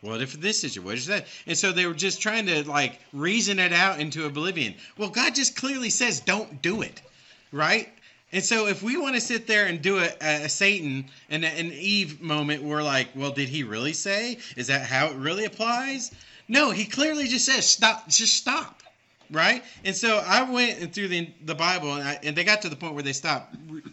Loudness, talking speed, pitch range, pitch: -24 LUFS, 220 wpm, 150-220 Hz, 185 Hz